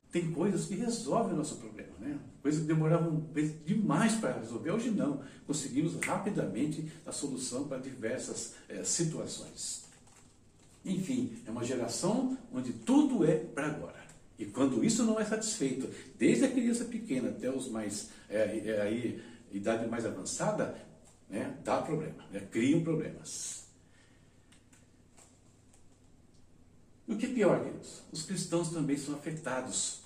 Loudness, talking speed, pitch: -33 LUFS, 140 wpm, 165 Hz